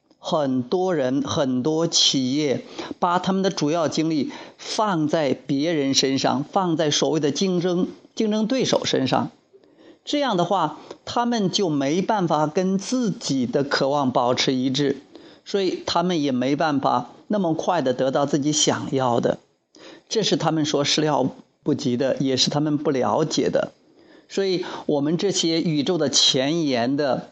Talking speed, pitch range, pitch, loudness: 225 characters per minute, 150-200 Hz, 170 Hz, -22 LUFS